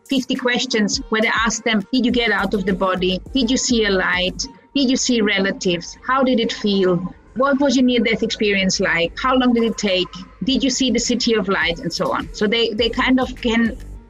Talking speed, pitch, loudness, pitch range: 230 wpm, 230 Hz, -18 LUFS, 195-255 Hz